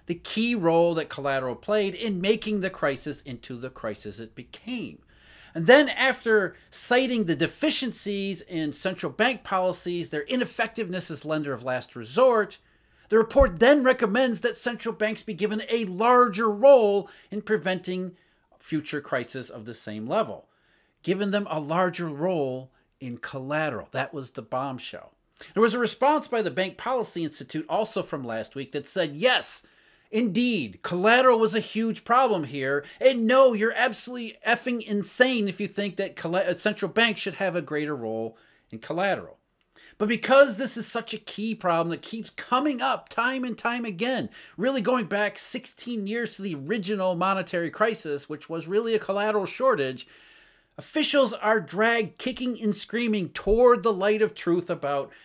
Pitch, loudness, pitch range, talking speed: 210 Hz, -25 LUFS, 165-235 Hz, 160 wpm